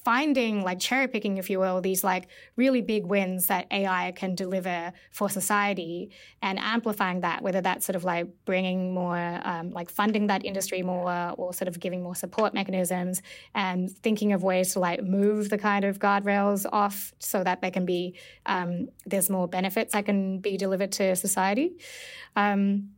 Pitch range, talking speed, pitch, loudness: 180-205 Hz, 180 wpm, 190 Hz, -27 LUFS